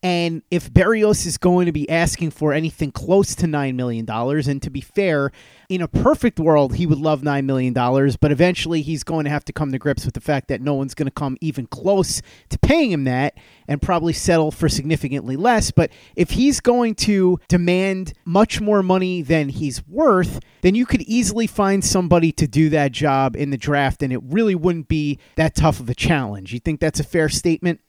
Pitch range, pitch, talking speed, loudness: 140-180 Hz, 155 Hz, 215 wpm, -19 LUFS